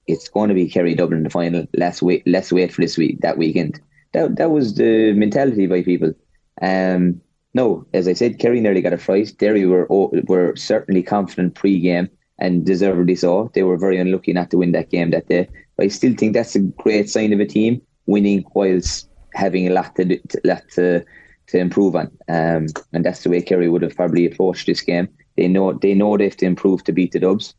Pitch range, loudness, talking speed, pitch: 90-100 Hz, -18 LUFS, 220 wpm, 90 Hz